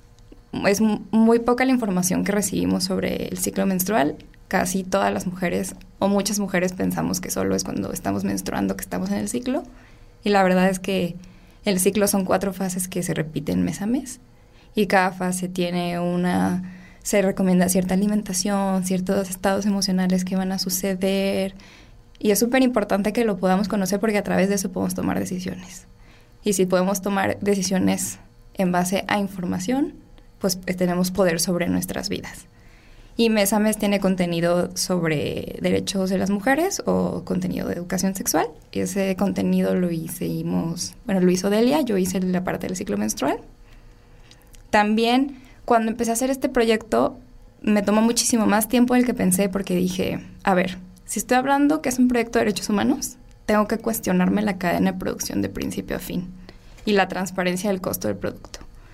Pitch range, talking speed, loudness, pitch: 175-210 Hz, 175 wpm, -22 LUFS, 190 Hz